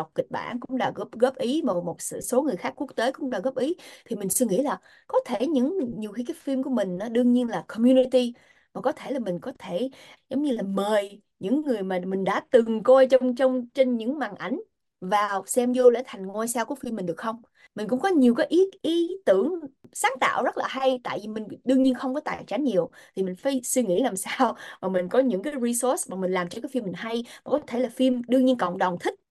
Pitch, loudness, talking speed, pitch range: 255 Hz, -25 LUFS, 260 wpm, 215-270 Hz